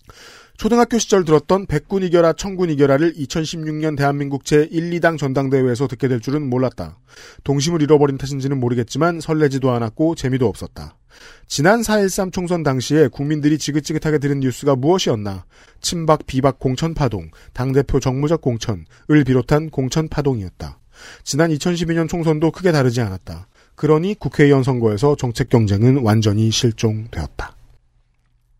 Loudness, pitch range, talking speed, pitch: -18 LUFS, 125-160 Hz, 340 characters per minute, 140 Hz